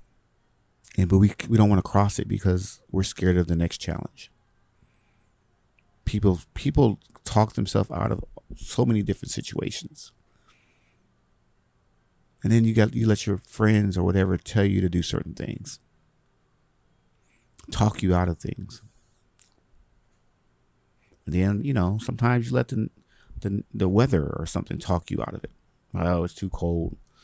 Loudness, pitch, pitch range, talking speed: -25 LUFS, 100 Hz, 90-115 Hz, 150 wpm